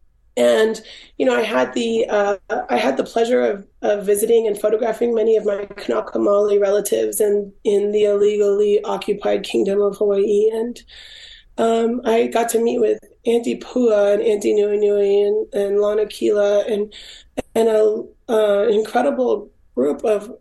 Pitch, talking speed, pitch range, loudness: 210 Hz, 155 wpm, 205-230 Hz, -18 LUFS